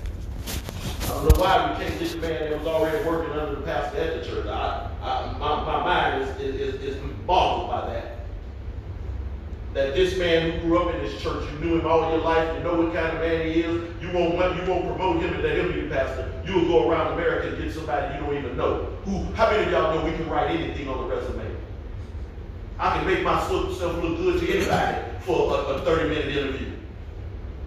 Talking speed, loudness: 215 wpm, -25 LUFS